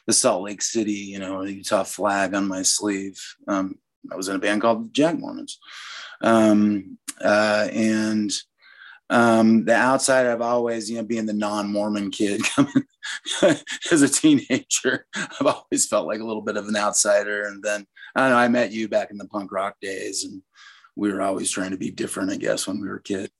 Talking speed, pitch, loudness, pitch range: 190 wpm, 110 Hz, -22 LUFS, 105-135 Hz